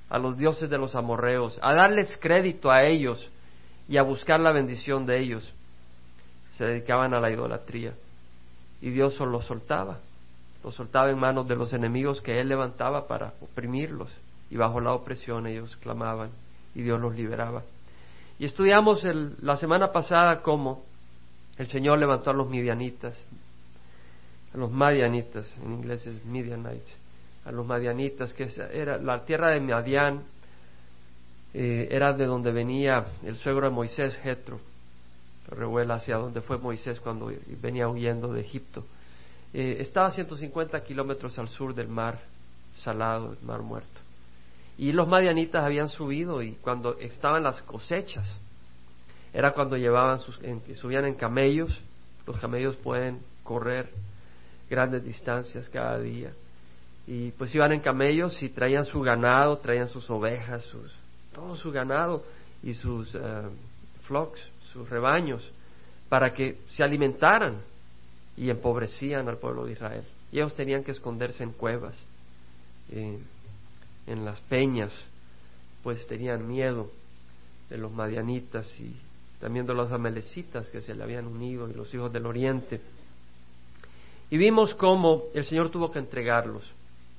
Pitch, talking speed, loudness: 120 Hz, 145 wpm, -27 LUFS